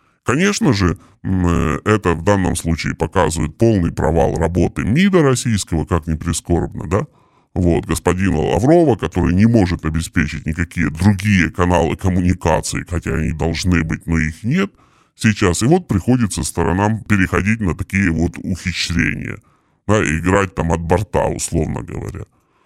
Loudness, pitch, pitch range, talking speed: -17 LUFS, 90 Hz, 80-105 Hz, 135 wpm